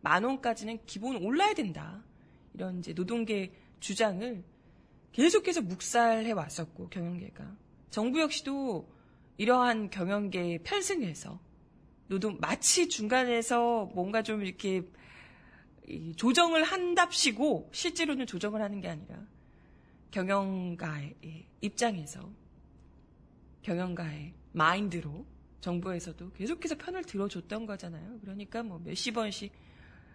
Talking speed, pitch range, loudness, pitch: 260 characters per minute, 175-240 Hz, -31 LUFS, 200 Hz